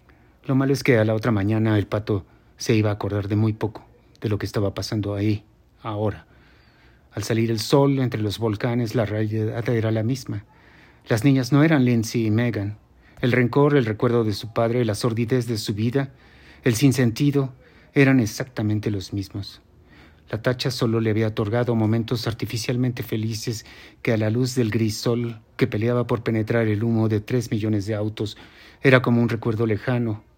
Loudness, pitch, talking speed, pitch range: -22 LUFS, 115 Hz, 185 wpm, 105-125 Hz